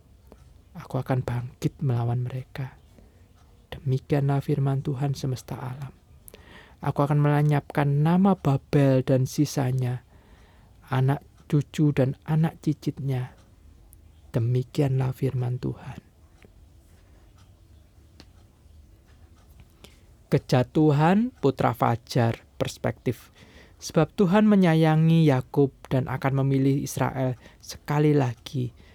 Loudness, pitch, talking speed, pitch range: -25 LUFS, 130 Hz, 80 wpm, 95-145 Hz